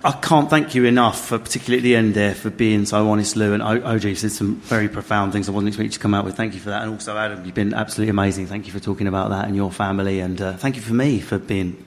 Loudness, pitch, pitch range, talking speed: -20 LUFS, 105 Hz, 100-115 Hz, 295 wpm